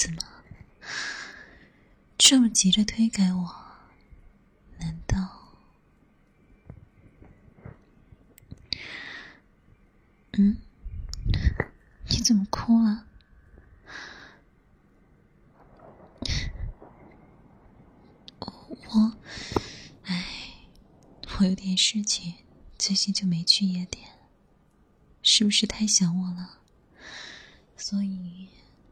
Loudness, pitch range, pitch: -24 LUFS, 180-215 Hz, 195 Hz